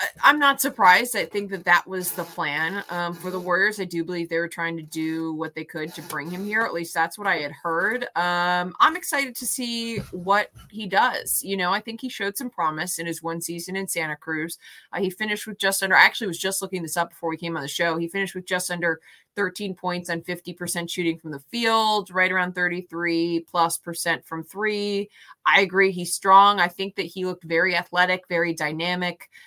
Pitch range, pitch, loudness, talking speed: 170-195 Hz, 180 Hz, -23 LUFS, 225 wpm